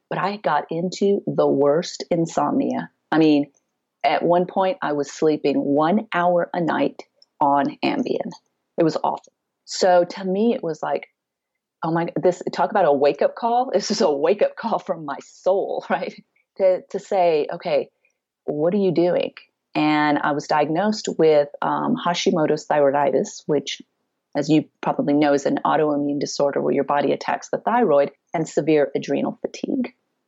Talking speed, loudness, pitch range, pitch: 165 wpm, -21 LUFS, 145-185 Hz, 165 Hz